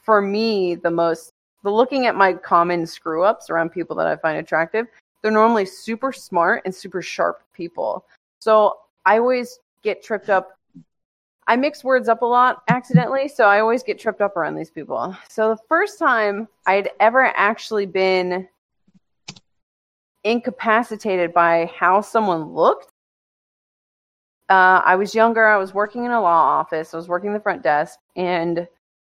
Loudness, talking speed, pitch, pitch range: -19 LUFS, 160 wpm, 200 Hz, 175-225 Hz